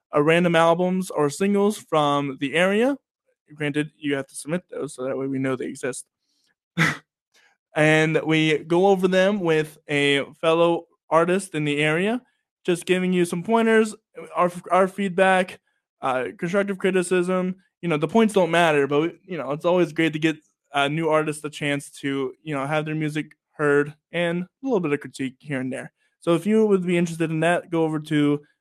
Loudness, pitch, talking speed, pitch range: -22 LUFS, 165 Hz, 190 wpm, 150-185 Hz